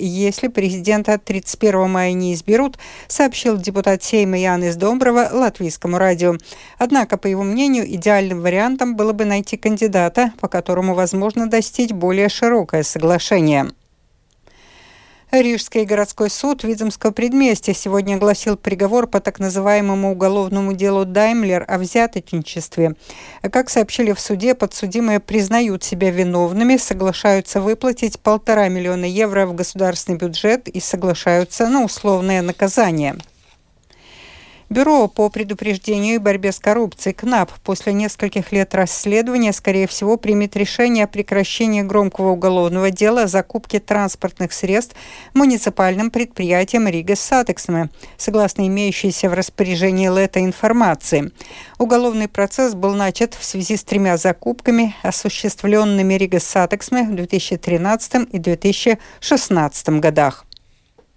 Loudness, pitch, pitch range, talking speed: -17 LUFS, 200 Hz, 185-225 Hz, 120 wpm